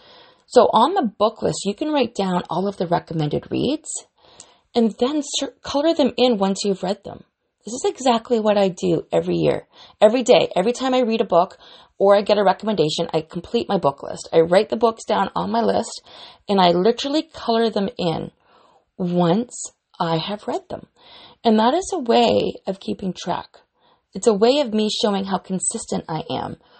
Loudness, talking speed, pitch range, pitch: -20 LUFS, 195 wpm, 185-245 Hz, 215 Hz